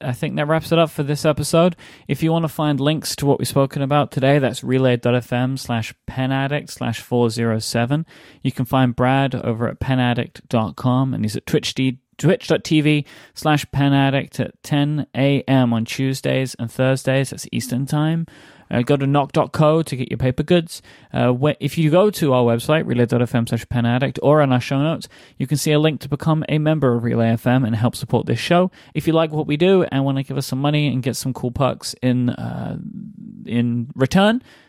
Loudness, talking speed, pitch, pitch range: -19 LUFS, 200 wpm, 135 Hz, 125-150 Hz